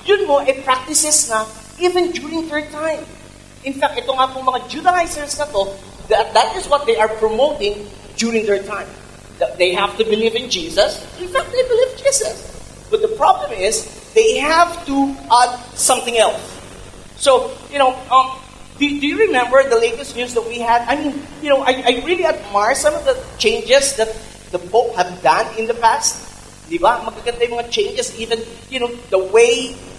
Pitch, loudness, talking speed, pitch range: 260 Hz, -17 LUFS, 180 wpm, 230-315 Hz